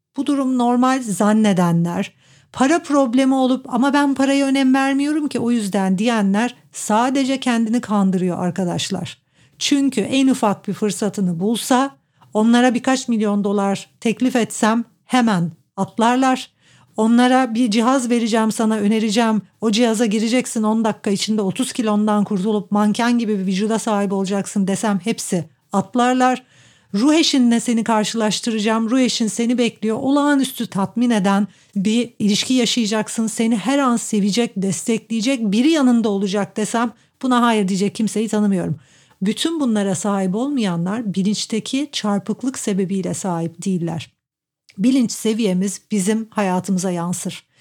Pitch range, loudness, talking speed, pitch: 200-245 Hz, -18 LUFS, 125 wpm, 220 Hz